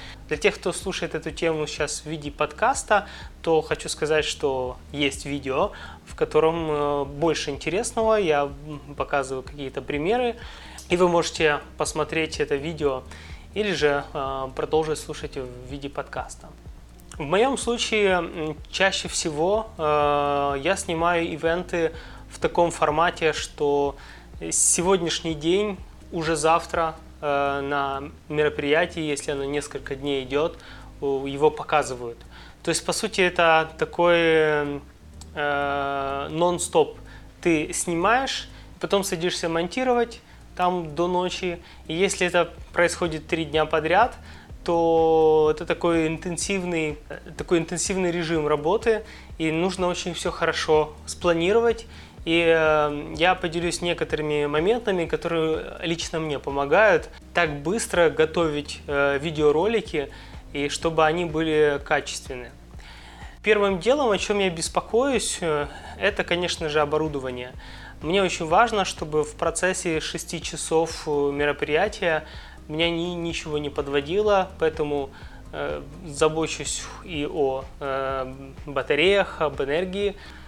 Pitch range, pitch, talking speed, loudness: 145-175 Hz, 160 Hz, 110 wpm, -24 LUFS